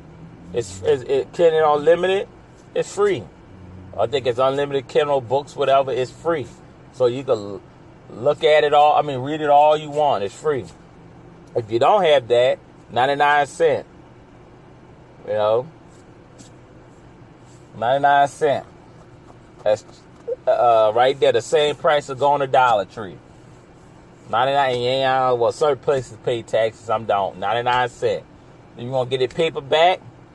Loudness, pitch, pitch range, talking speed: -19 LUFS, 145 Hz, 130-175 Hz, 160 wpm